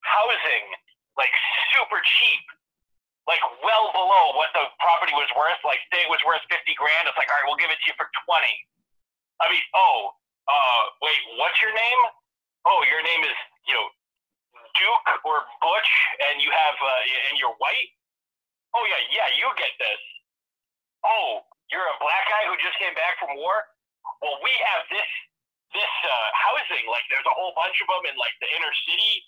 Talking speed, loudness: 180 wpm, -21 LUFS